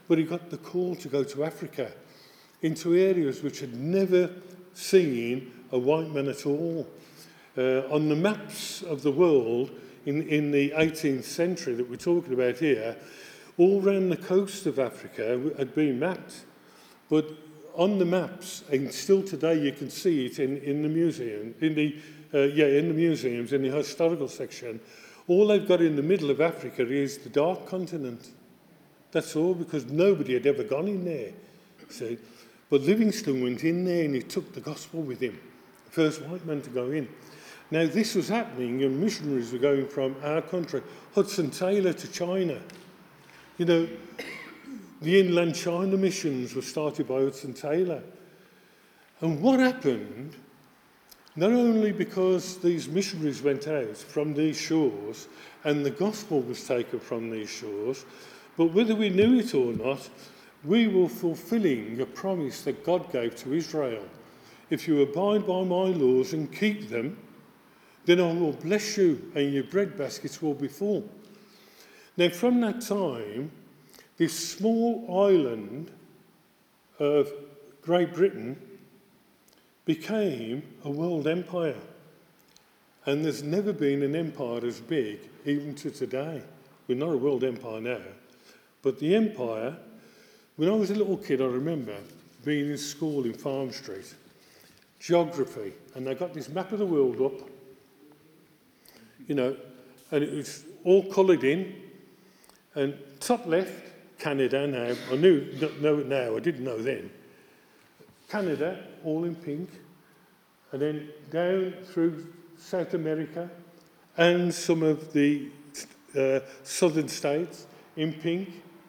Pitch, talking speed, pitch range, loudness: 160 Hz, 150 wpm, 140-185 Hz, -27 LUFS